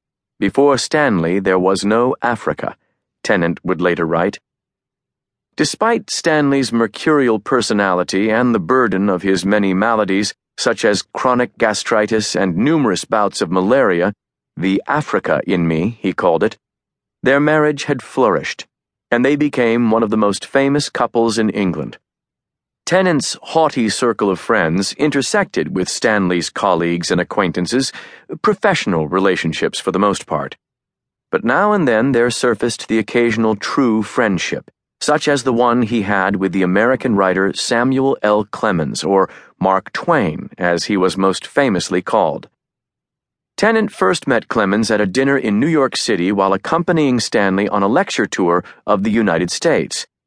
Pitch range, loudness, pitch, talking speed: 95-130 Hz, -16 LUFS, 110 Hz, 145 wpm